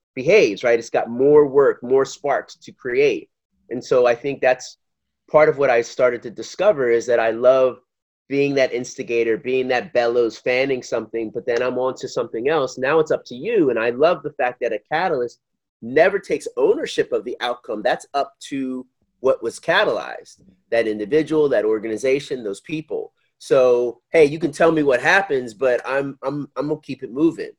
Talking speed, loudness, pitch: 195 wpm, -20 LUFS, 135 Hz